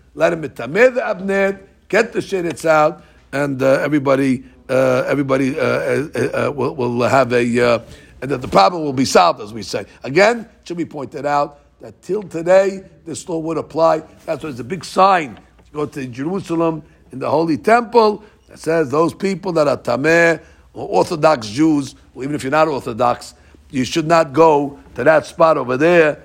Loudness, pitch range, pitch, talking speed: -17 LUFS, 135-180 Hz, 155 Hz, 190 wpm